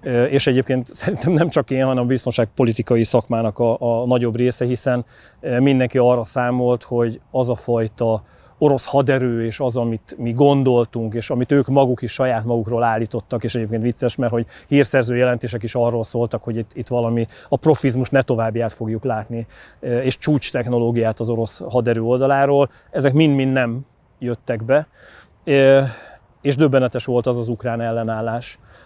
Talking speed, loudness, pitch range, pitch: 155 wpm, -19 LUFS, 115-130 Hz, 125 Hz